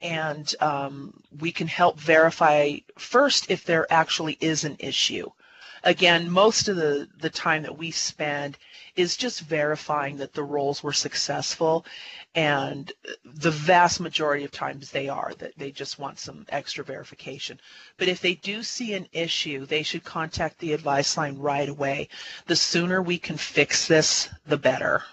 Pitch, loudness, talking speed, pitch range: 160 Hz, -24 LUFS, 160 wpm, 145-175 Hz